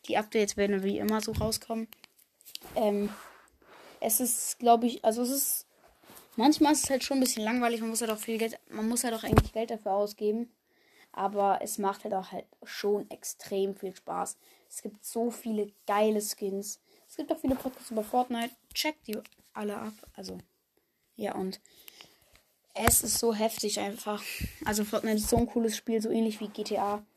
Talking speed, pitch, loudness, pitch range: 190 wpm, 220 Hz, -30 LUFS, 205-235 Hz